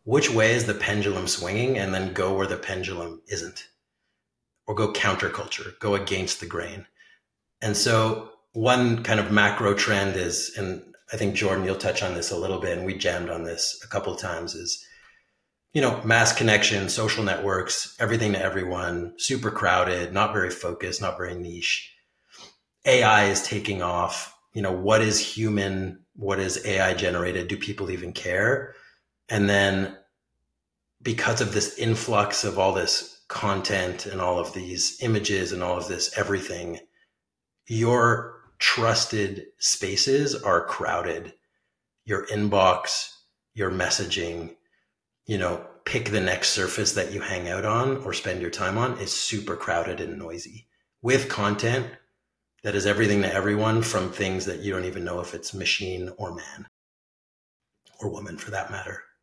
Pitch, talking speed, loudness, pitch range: 100 Hz, 160 wpm, -25 LUFS, 90-110 Hz